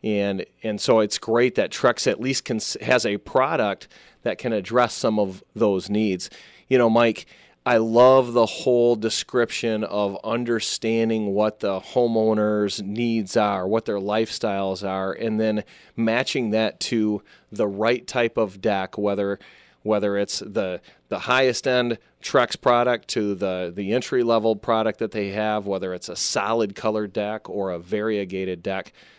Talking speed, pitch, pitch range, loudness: 160 wpm, 110 Hz, 100-115 Hz, -23 LUFS